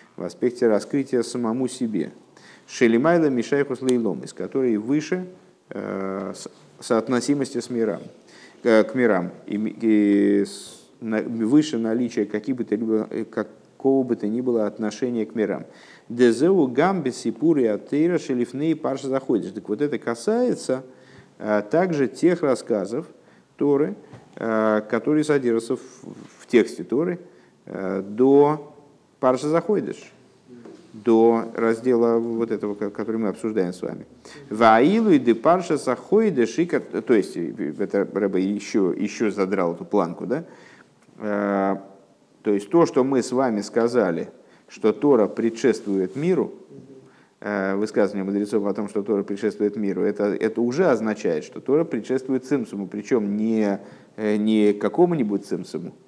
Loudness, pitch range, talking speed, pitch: -22 LUFS, 105-130 Hz, 125 wpm, 115 Hz